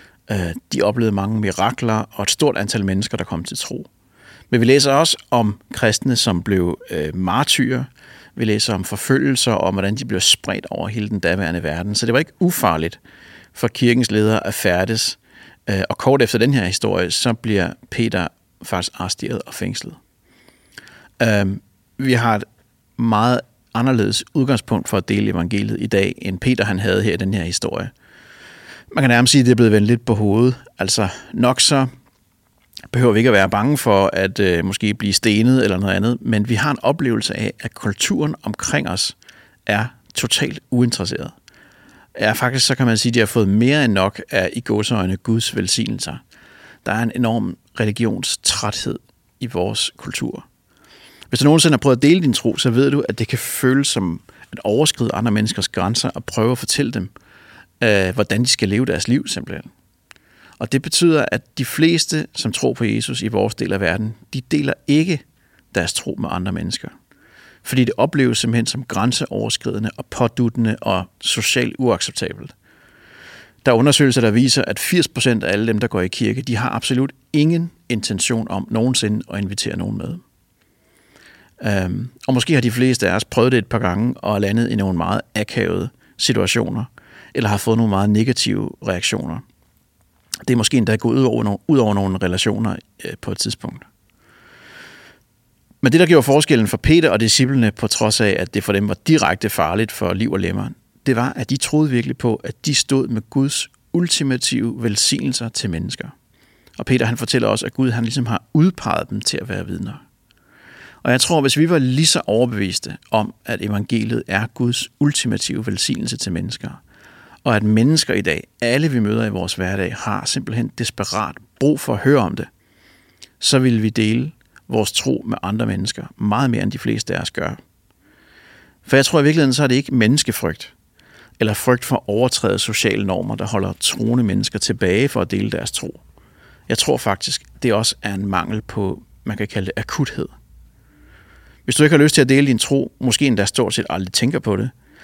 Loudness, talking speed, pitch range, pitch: -18 LUFS, 185 wpm, 105-130 Hz, 115 Hz